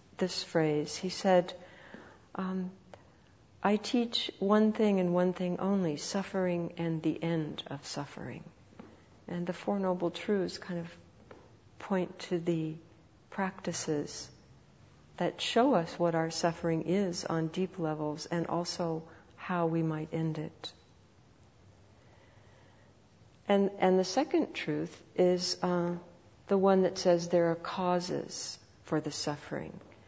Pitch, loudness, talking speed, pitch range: 170 Hz, -32 LUFS, 130 wpm, 155-185 Hz